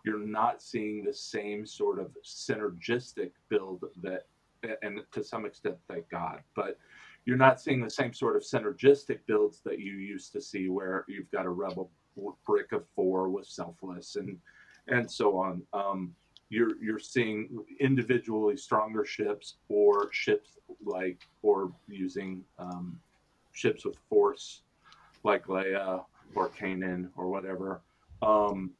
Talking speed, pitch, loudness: 140 wpm, 110 Hz, -31 LUFS